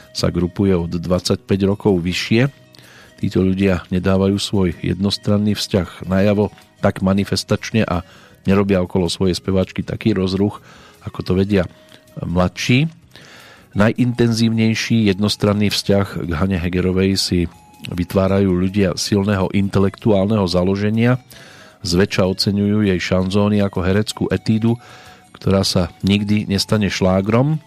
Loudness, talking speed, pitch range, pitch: -18 LUFS, 110 wpm, 95-105 Hz, 100 Hz